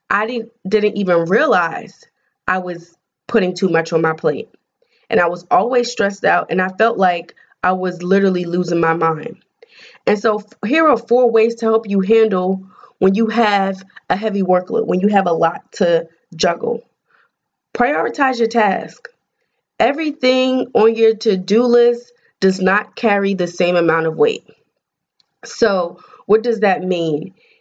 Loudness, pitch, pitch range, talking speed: -16 LUFS, 200 Hz, 180-230 Hz, 160 wpm